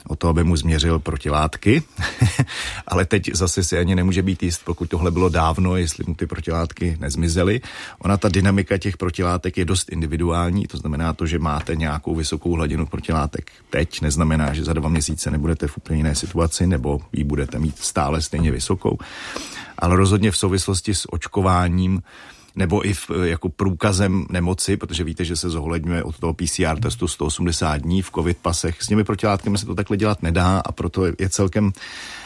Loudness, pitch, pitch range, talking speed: -21 LUFS, 85 Hz, 80-95 Hz, 175 wpm